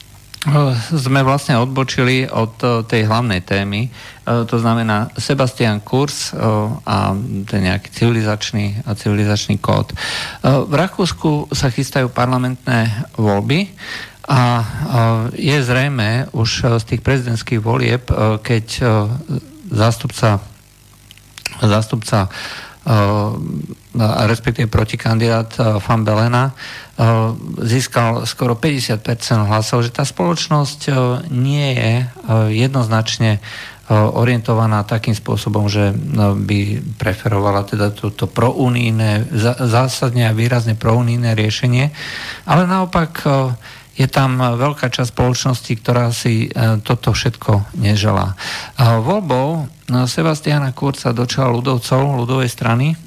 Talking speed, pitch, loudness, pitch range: 95 wpm, 120 Hz, -16 LUFS, 110-130 Hz